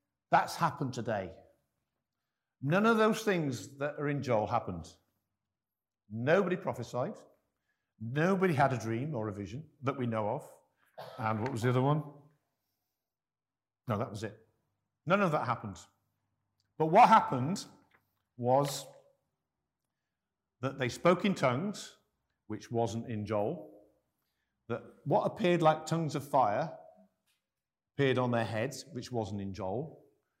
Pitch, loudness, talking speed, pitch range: 125 Hz, -32 LUFS, 130 wpm, 105-145 Hz